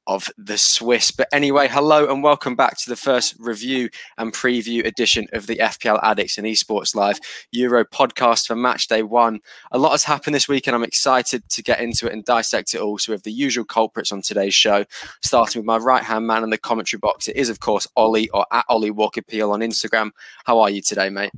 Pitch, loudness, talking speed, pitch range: 115 Hz, -18 LUFS, 230 wpm, 110-125 Hz